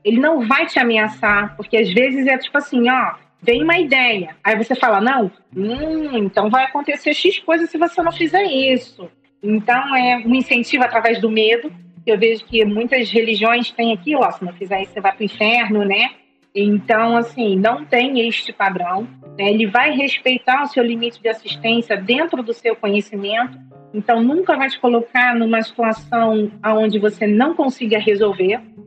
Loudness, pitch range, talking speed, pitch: -16 LUFS, 210-255 Hz, 180 wpm, 230 Hz